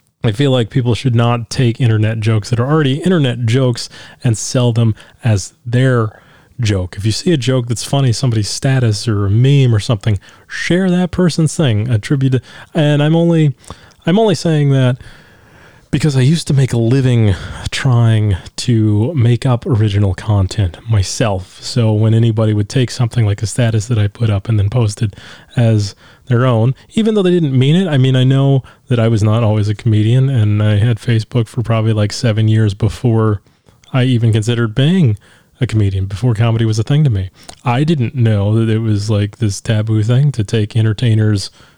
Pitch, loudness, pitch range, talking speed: 115 Hz, -14 LUFS, 110-130 Hz, 190 wpm